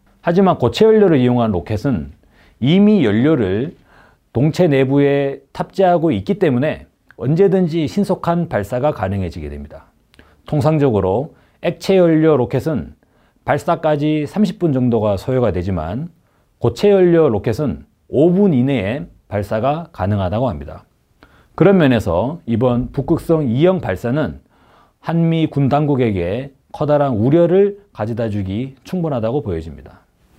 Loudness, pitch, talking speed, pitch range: -16 LUFS, 140 Hz, 280 characters per minute, 115-170 Hz